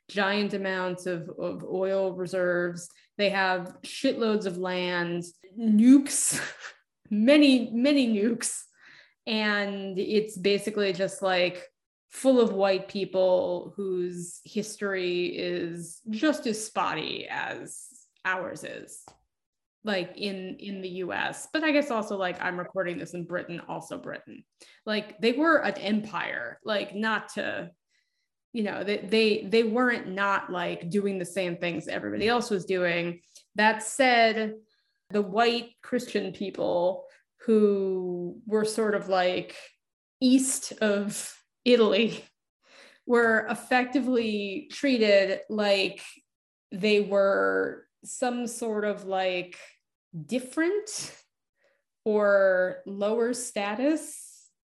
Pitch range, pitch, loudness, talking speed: 185-235 Hz, 205 Hz, -27 LUFS, 110 wpm